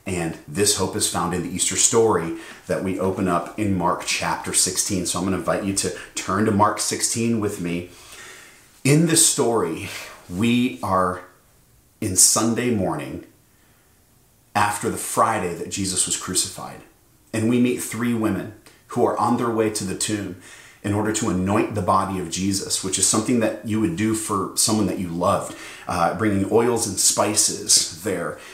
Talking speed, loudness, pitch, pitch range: 175 wpm, -21 LUFS, 100 Hz, 90-110 Hz